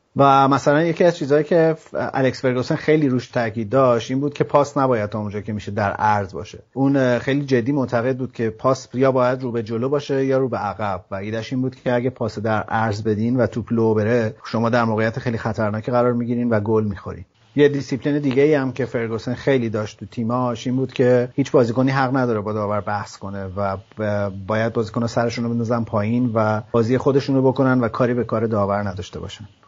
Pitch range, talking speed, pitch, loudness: 110-130 Hz, 210 wpm, 120 Hz, -20 LUFS